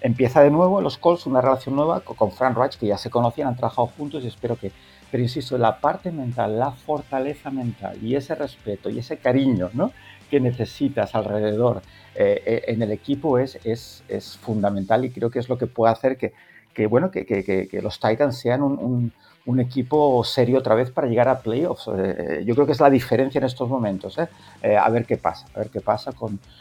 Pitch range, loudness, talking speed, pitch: 110-140 Hz, -22 LUFS, 210 wpm, 125 Hz